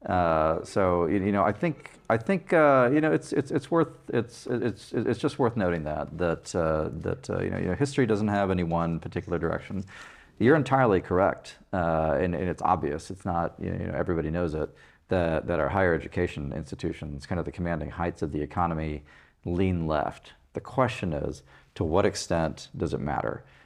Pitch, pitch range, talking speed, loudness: 85 Hz, 80-105 Hz, 195 wpm, -27 LUFS